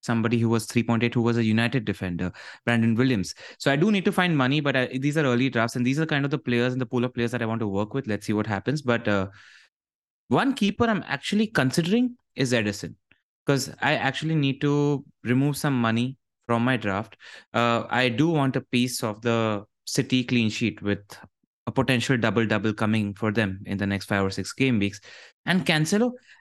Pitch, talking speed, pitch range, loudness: 120 Hz, 215 wpm, 110-140 Hz, -25 LUFS